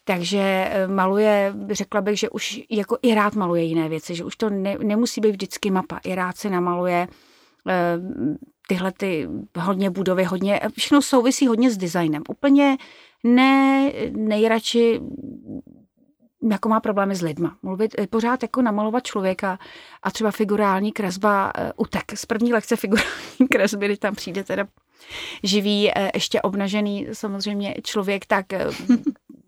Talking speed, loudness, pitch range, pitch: 145 wpm, -22 LUFS, 195-235 Hz, 210 Hz